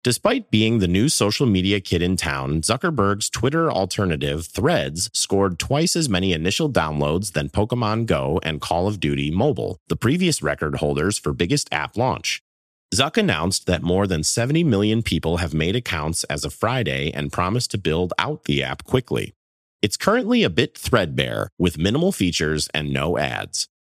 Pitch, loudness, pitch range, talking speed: 90 Hz, -21 LUFS, 80-110 Hz, 170 wpm